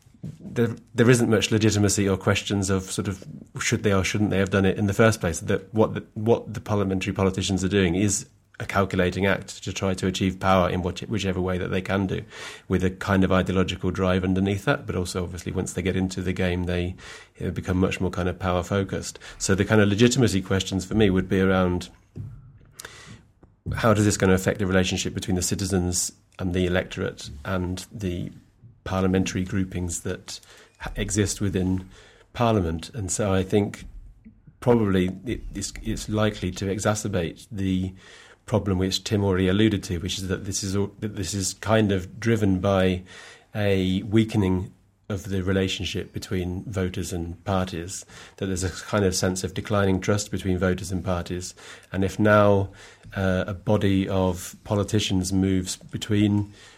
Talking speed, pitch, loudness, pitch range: 185 wpm, 95 Hz, -24 LUFS, 95-105 Hz